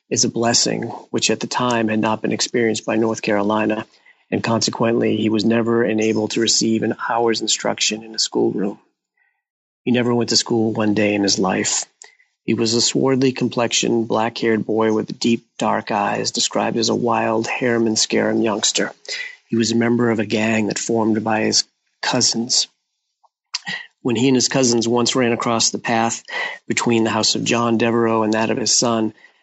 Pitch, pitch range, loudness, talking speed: 115 Hz, 110-115 Hz, -18 LUFS, 180 wpm